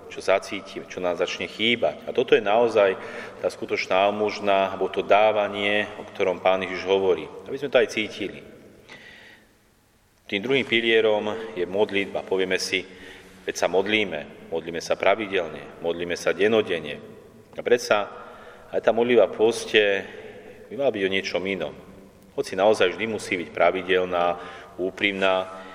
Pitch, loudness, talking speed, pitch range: 100 Hz, -23 LUFS, 140 wpm, 95-115 Hz